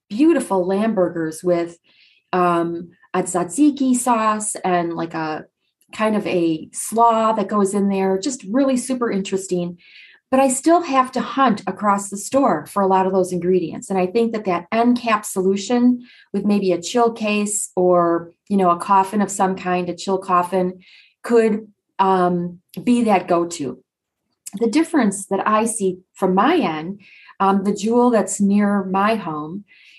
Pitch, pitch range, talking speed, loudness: 200 Hz, 180-230 Hz, 165 wpm, -19 LUFS